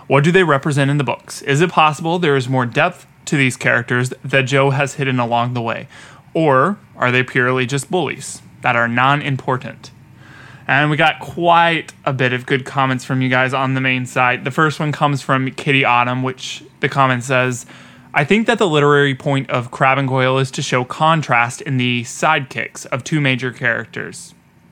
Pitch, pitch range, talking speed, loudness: 135 Hz, 125-145 Hz, 200 wpm, -16 LUFS